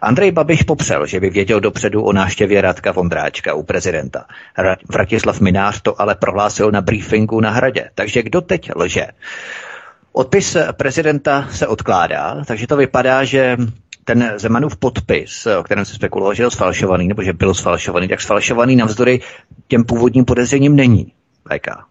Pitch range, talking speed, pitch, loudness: 105-140 Hz, 155 wpm, 120 Hz, -15 LUFS